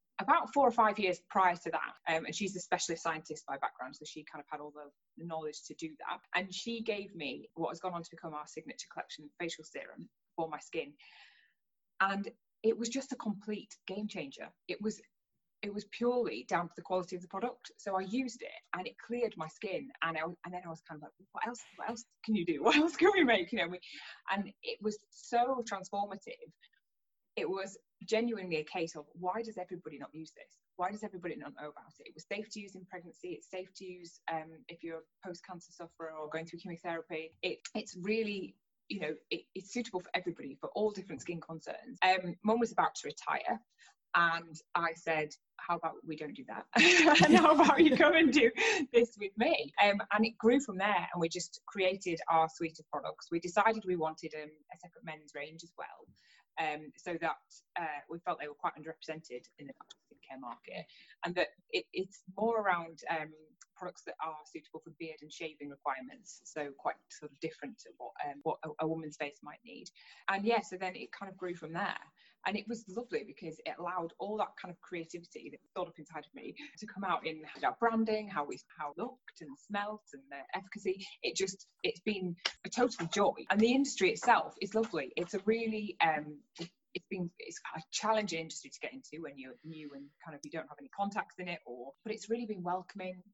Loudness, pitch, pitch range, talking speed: -34 LUFS, 180 Hz, 160-215 Hz, 220 wpm